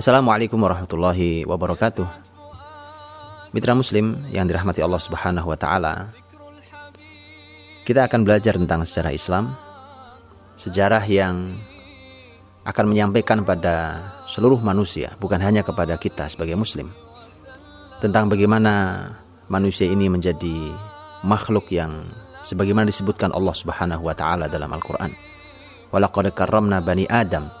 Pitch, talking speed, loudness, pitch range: 95 Hz, 105 wpm, -21 LUFS, 90-105 Hz